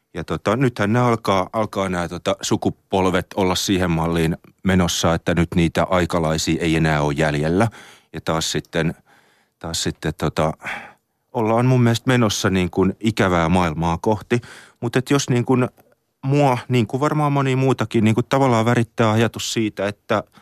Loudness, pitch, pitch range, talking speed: -20 LUFS, 100 Hz, 85-120 Hz, 155 wpm